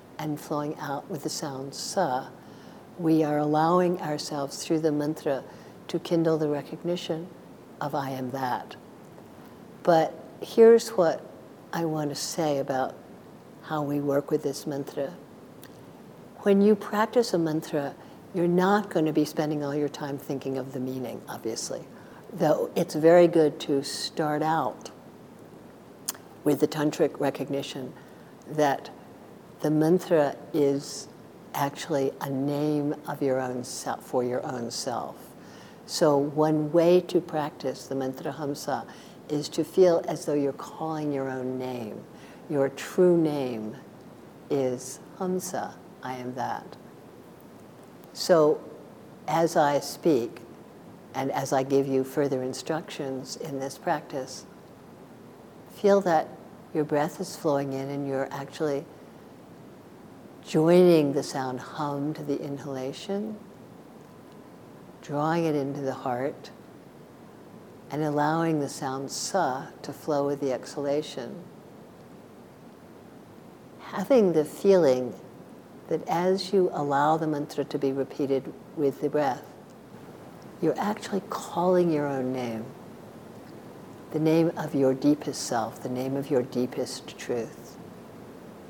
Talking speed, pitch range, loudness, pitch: 125 wpm, 135-165 Hz, -27 LUFS, 150 Hz